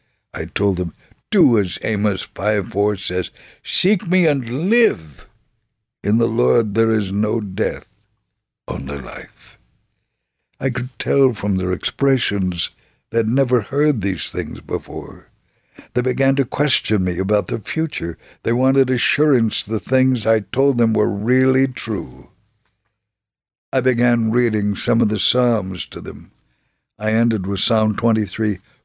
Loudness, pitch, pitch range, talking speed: -19 LUFS, 115 Hz, 100-130 Hz, 140 wpm